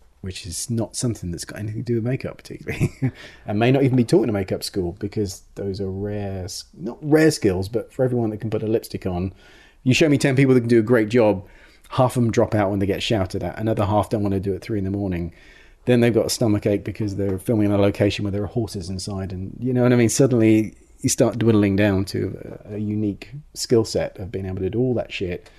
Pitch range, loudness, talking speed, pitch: 100-120 Hz, -21 LUFS, 265 wpm, 105 Hz